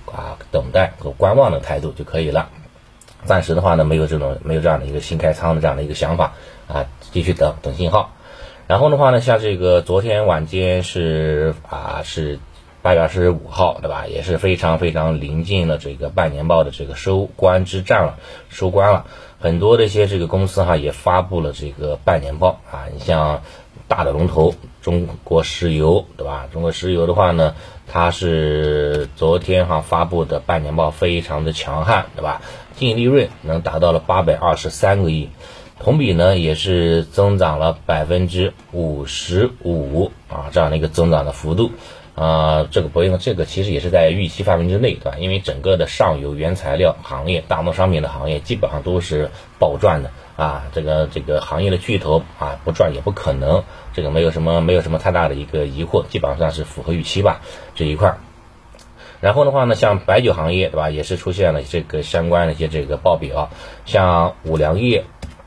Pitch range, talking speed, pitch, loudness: 75-90 Hz, 295 characters per minute, 80 Hz, -18 LUFS